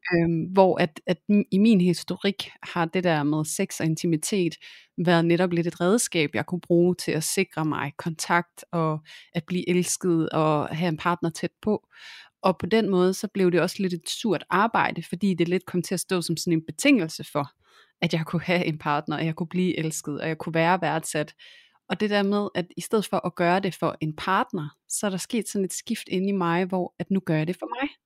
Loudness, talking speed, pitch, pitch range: -25 LUFS, 235 wpm, 175 Hz, 160-190 Hz